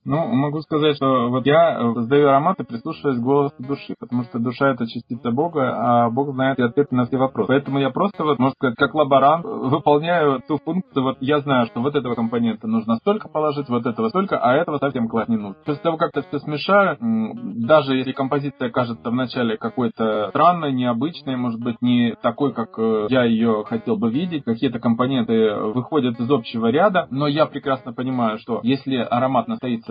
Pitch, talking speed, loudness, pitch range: 135 Hz, 185 wpm, -20 LUFS, 120-150 Hz